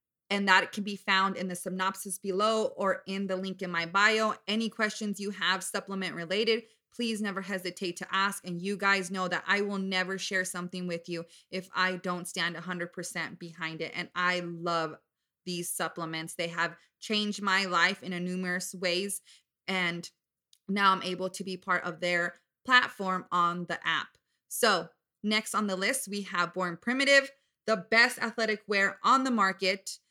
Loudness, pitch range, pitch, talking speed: -29 LUFS, 175-200 Hz, 185 Hz, 175 wpm